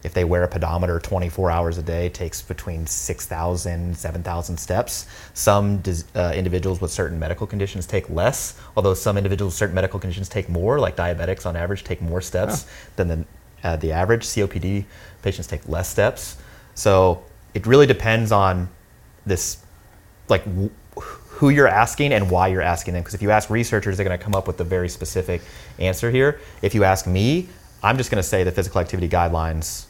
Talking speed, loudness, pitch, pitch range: 185 wpm, -21 LUFS, 95 Hz, 90-100 Hz